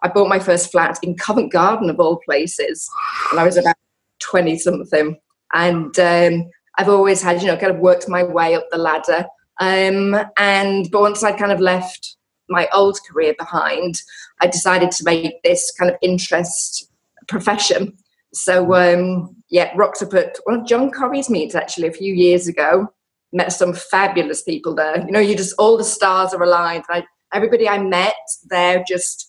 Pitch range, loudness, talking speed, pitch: 175-200 Hz, -16 LUFS, 180 wpm, 180 Hz